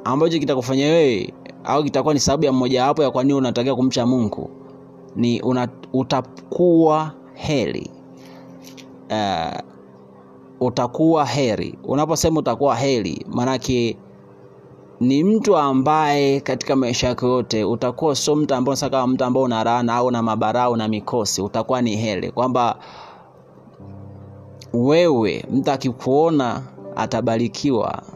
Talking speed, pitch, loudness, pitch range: 115 wpm, 125 Hz, -19 LUFS, 115-140 Hz